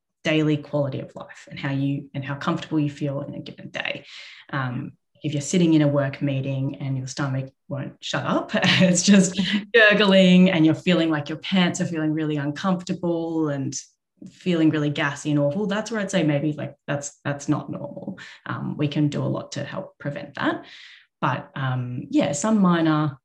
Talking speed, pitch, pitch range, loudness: 190 wpm, 155 Hz, 145-180 Hz, -22 LUFS